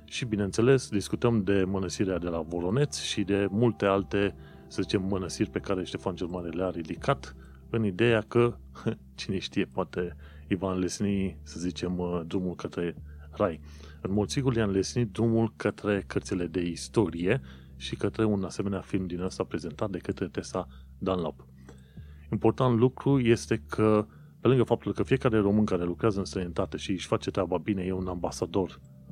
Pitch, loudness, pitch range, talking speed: 95 Hz, -29 LUFS, 85-110 Hz, 165 wpm